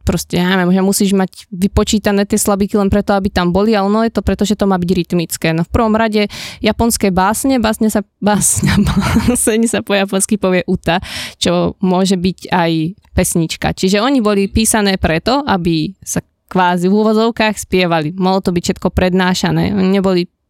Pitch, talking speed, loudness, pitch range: 195 Hz, 180 wpm, -14 LUFS, 185-215 Hz